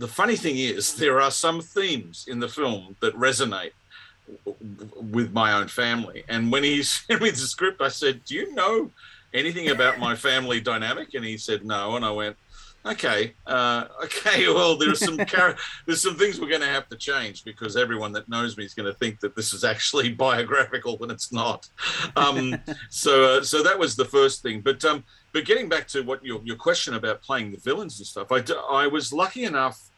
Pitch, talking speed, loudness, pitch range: 125 Hz, 210 wpm, -23 LUFS, 110-155 Hz